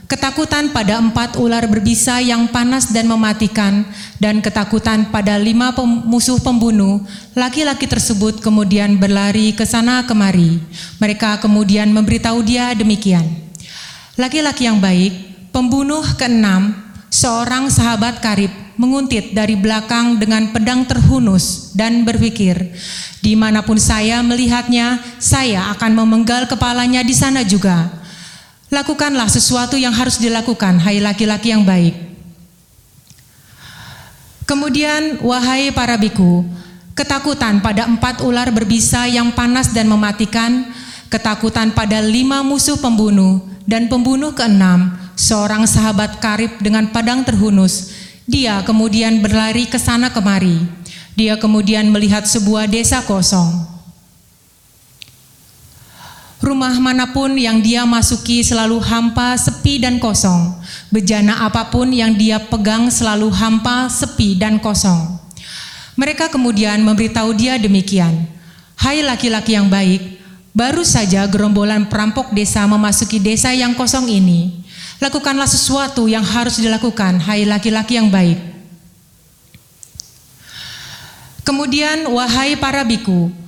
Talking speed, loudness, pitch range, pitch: 110 wpm, -14 LUFS, 200-245 Hz, 220 Hz